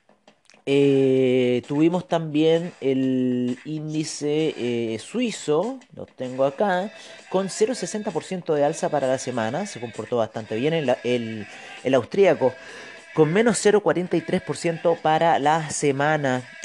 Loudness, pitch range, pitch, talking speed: -23 LUFS, 130-175 Hz, 150 Hz, 110 wpm